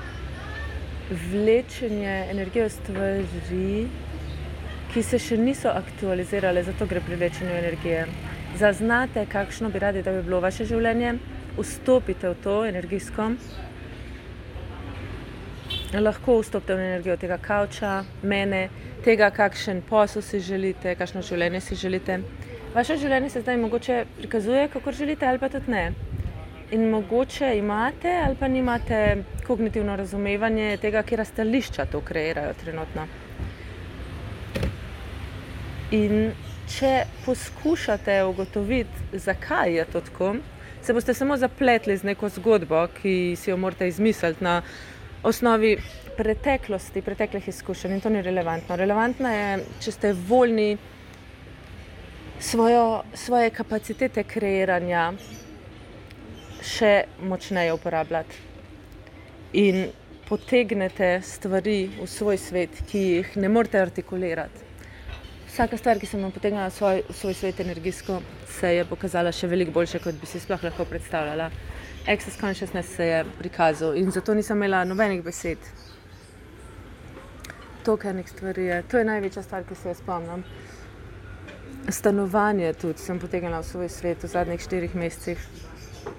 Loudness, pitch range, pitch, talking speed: -25 LUFS, 165-215 Hz, 190 Hz, 125 wpm